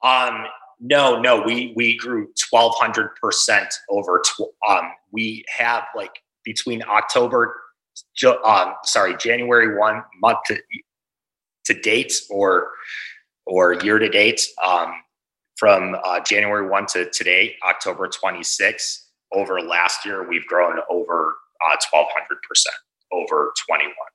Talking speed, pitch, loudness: 120 wpm, 125 Hz, -19 LUFS